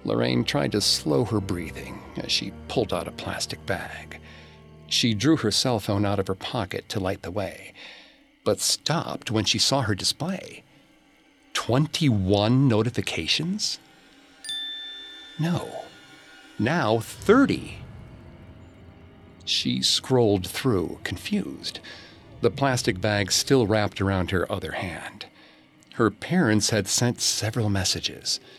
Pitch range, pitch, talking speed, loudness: 90-125 Hz, 105 Hz, 120 wpm, -24 LUFS